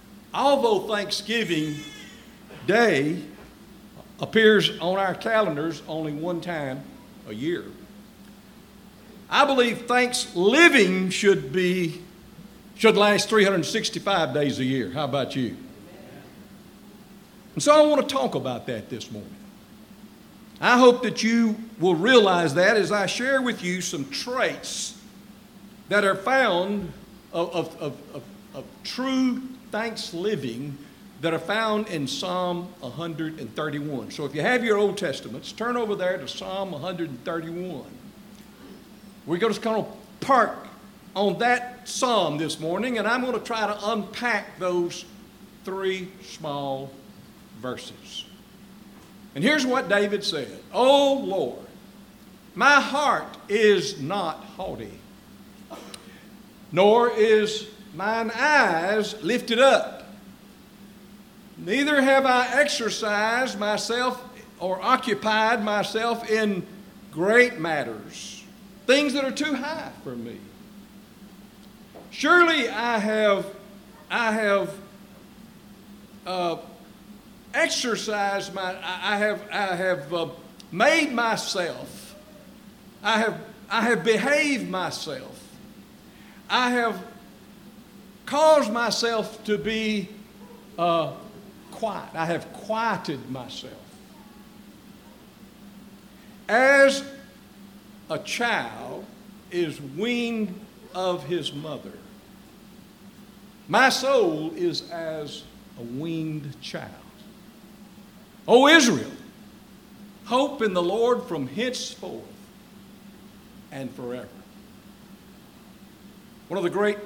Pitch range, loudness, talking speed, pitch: 190-225 Hz, -23 LUFS, 105 wpm, 205 Hz